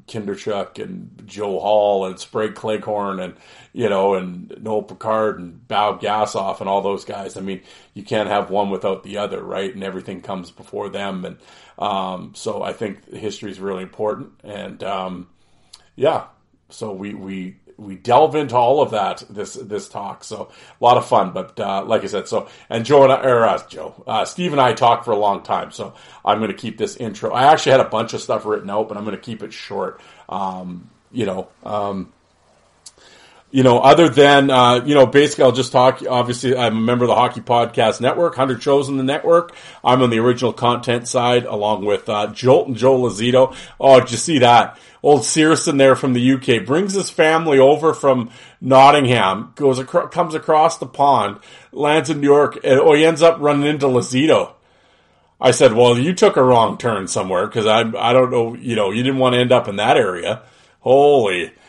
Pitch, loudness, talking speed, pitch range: 120 Hz, -16 LUFS, 205 wpm, 105-135 Hz